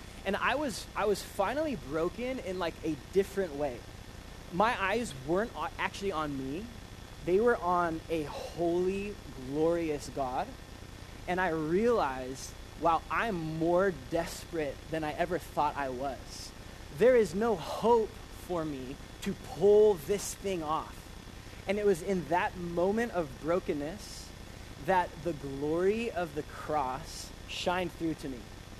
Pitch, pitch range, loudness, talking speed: 165 Hz, 135-190 Hz, -32 LUFS, 140 wpm